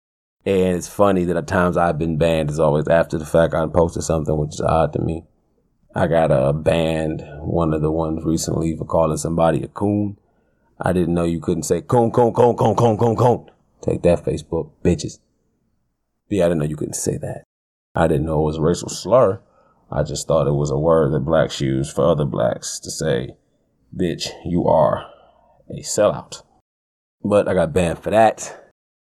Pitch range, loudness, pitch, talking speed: 75-90 Hz, -19 LUFS, 80 Hz, 195 wpm